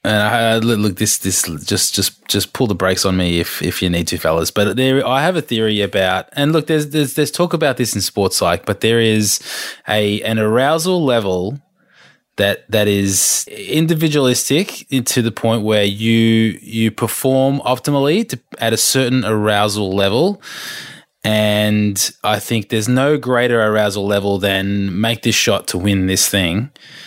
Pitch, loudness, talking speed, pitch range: 110 Hz, -16 LUFS, 175 wpm, 100-130 Hz